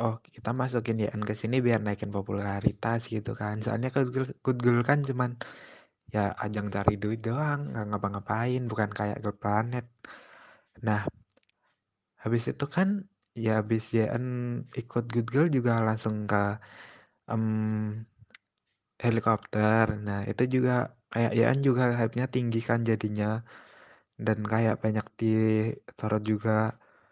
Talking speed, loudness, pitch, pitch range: 130 wpm, -29 LUFS, 115 Hz, 105-120 Hz